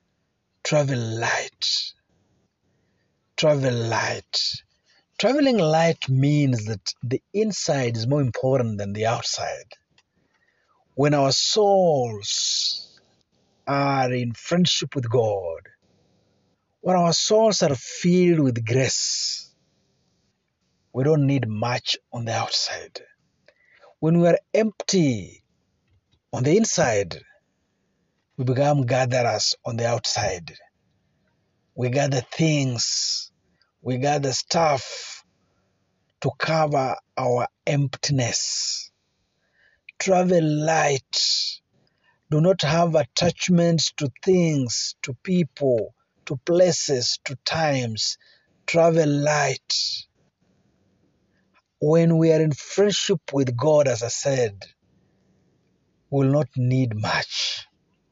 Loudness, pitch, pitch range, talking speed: -22 LUFS, 140 Hz, 125-165 Hz, 95 wpm